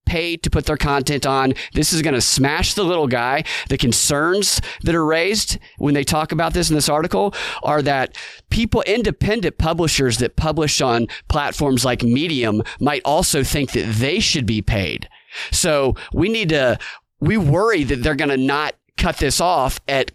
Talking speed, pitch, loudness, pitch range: 180 wpm, 145 Hz, -18 LUFS, 130-160 Hz